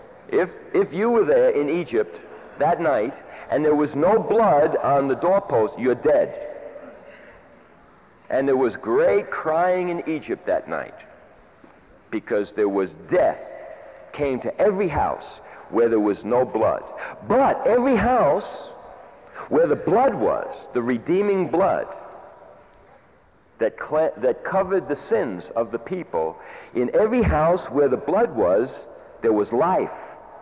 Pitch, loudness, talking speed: 175 Hz, -21 LUFS, 140 wpm